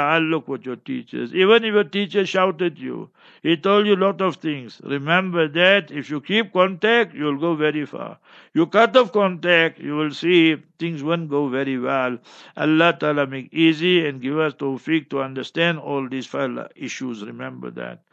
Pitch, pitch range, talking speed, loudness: 160 Hz, 140-185 Hz, 180 wpm, -20 LUFS